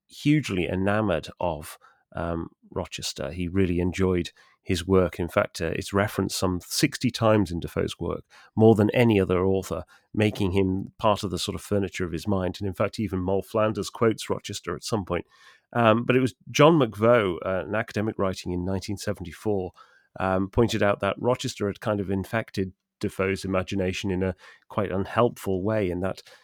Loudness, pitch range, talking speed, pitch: -26 LUFS, 95-110 Hz, 175 wpm, 100 Hz